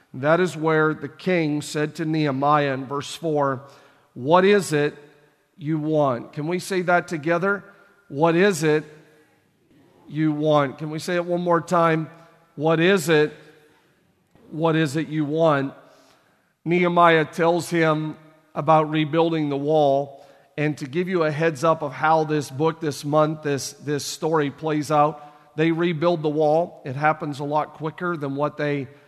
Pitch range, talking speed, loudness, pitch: 150-165 Hz, 160 wpm, -22 LUFS, 155 Hz